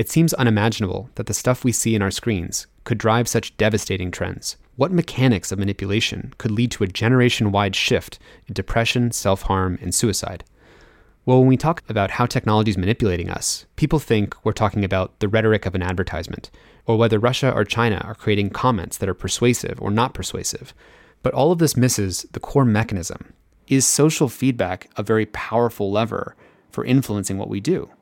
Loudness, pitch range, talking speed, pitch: -20 LUFS, 100-120 Hz, 185 wpm, 110 Hz